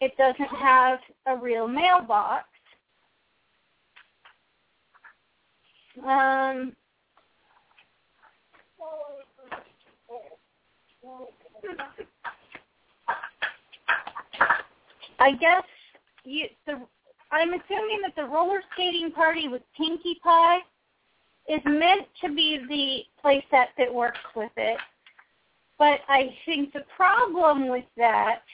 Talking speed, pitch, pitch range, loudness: 80 wpm, 290 Hz, 260-335 Hz, -24 LUFS